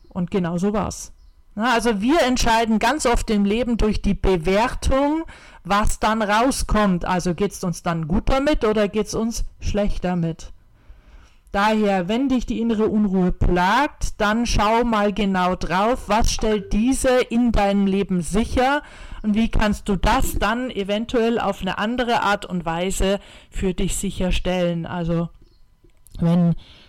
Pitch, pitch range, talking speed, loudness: 205 Hz, 185-230 Hz, 150 wpm, -21 LUFS